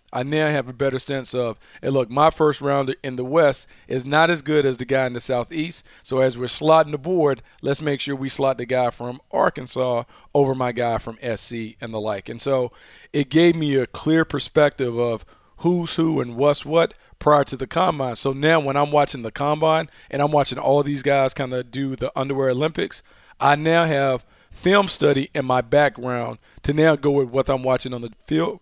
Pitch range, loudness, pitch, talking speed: 125-150 Hz, -21 LUFS, 135 Hz, 215 wpm